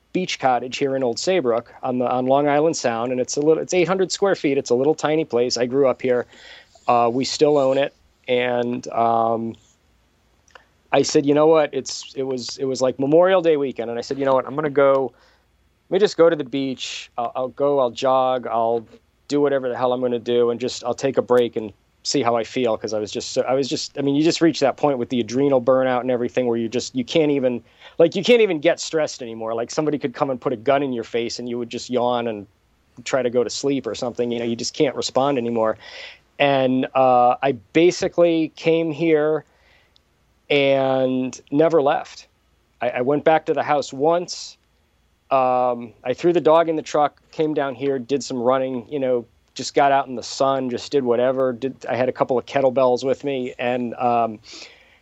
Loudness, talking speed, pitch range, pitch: -20 LUFS, 220 wpm, 120-145 Hz, 130 Hz